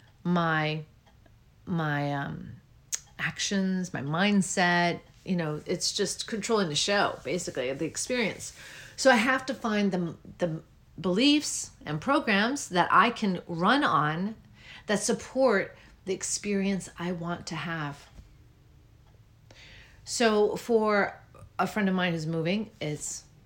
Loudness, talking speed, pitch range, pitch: -28 LUFS, 125 wpm, 145-205 Hz, 175 Hz